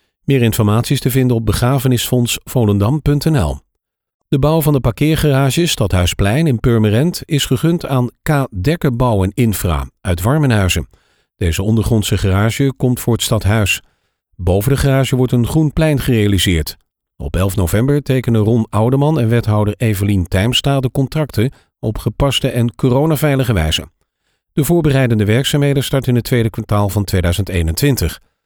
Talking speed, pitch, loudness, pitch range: 135 wpm, 120 Hz, -15 LUFS, 105-140 Hz